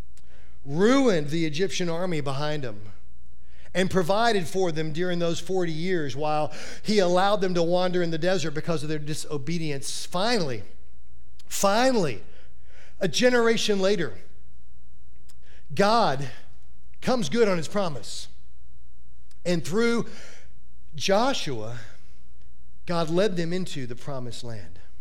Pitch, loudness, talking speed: 150 Hz, -26 LUFS, 115 wpm